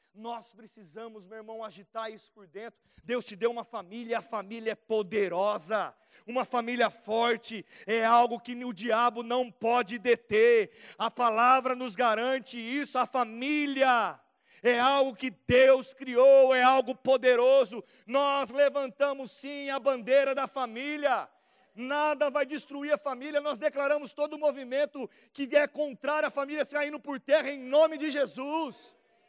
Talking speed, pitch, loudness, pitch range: 150 wpm, 255 Hz, -28 LUFS, 230-280 Hz